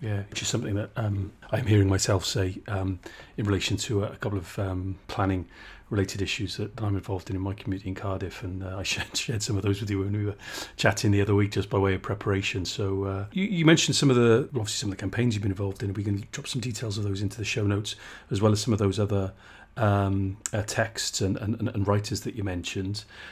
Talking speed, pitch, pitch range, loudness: 260 wpm, 100 Hz, 95-110 Hz, -27 LUFS